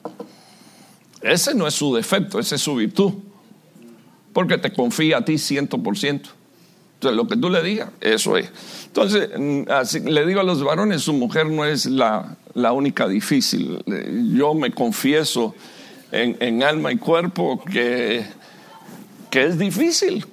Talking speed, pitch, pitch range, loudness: 150 wpm, 160 Hz, 145-215 Hz, -20 LUFS